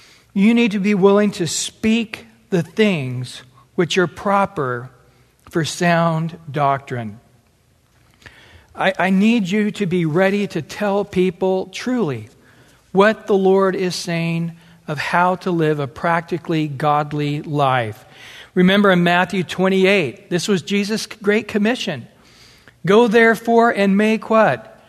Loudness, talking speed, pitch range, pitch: -18 LUFS, 130 wpm, 145-200 Hz, 180 Hz